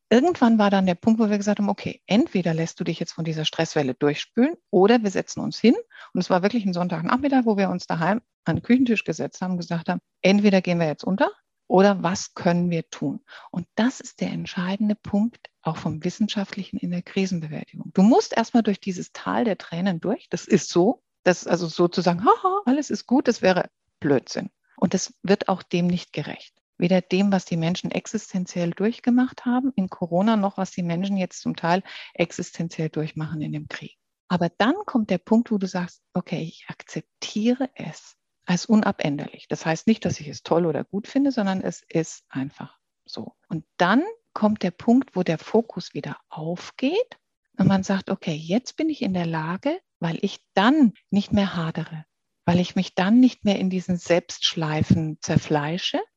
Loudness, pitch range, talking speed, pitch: -23 LUFS, 170-220 Hz, 190 wpm, 190 Hz